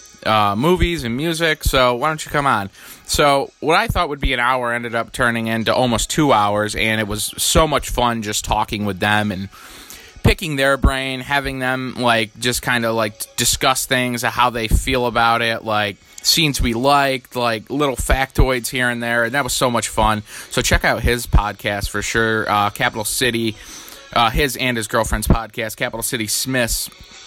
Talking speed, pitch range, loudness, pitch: 195 wpm, 110-130 Hz, -18 LUFS, 120 Hz